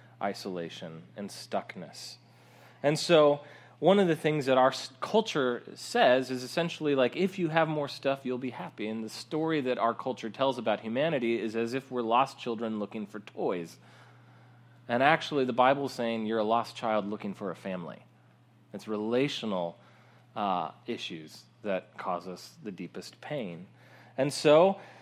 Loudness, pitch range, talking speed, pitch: -29 LUFS, 110-145 Hz, 160 wpm, 125 Hz